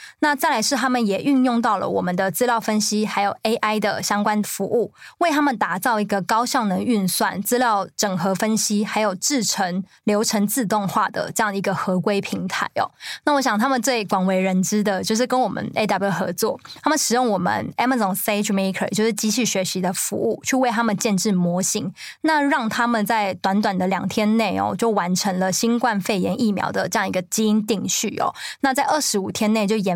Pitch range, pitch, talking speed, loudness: 195-235 Hz, 215 Hz, 325 characters per minute, -21 LUFS